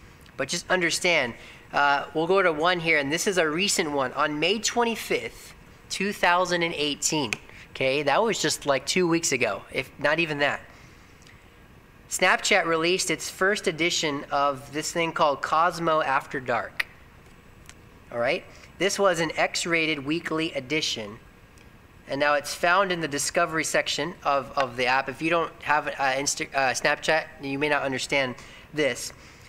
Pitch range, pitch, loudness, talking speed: 145-175 Hz, 160 Hz, -24 LUFS, 155 wpm